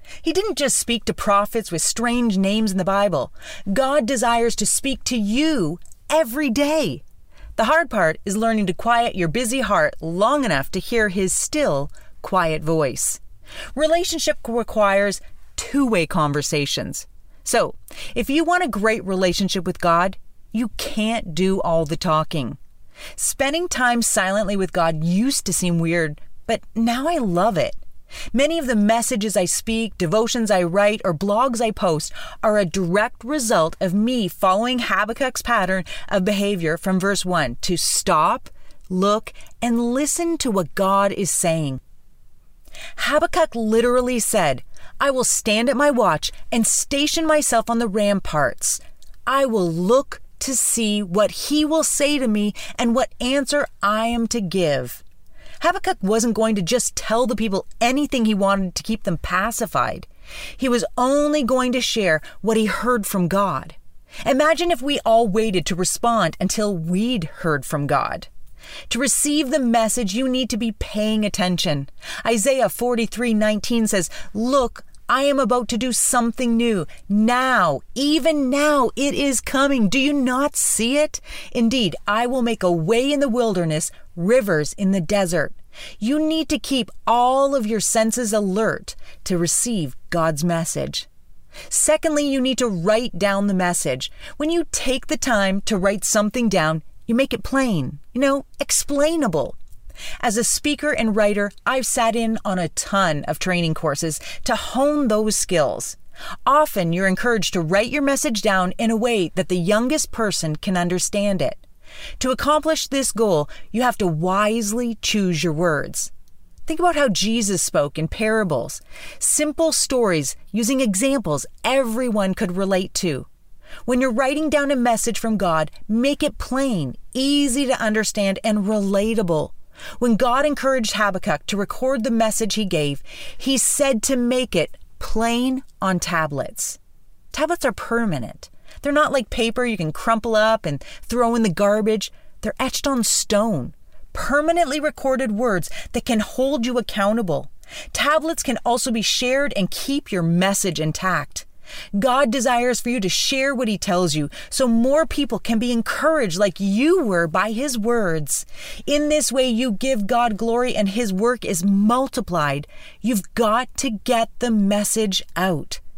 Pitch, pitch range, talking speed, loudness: 225 Hz, 195-260 Hz, 160 wpm, -20 LUFS